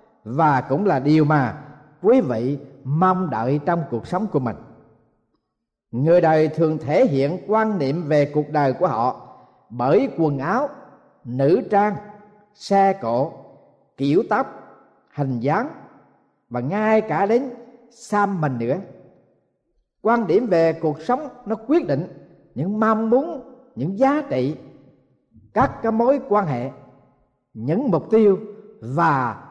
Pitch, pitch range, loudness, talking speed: 170 Hz, 140-215 Hz, -20 LUFS, 135 wpm